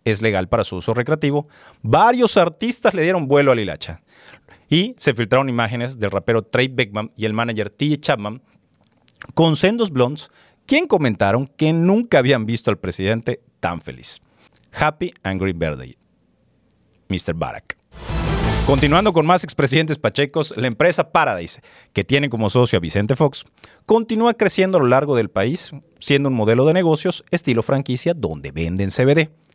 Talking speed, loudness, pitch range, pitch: 155 wpm, -18 LUFS, 110-160 Hz, 130 Hz